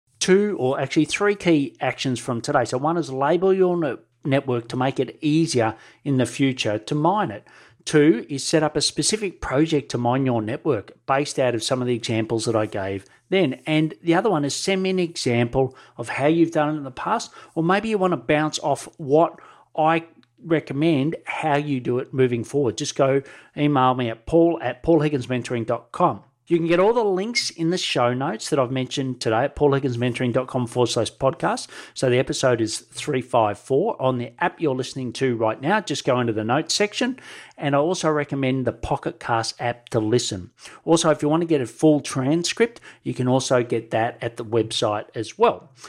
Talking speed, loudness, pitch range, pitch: 200 wpm, -22 LUFS, 125-160 Hz, 135 Hz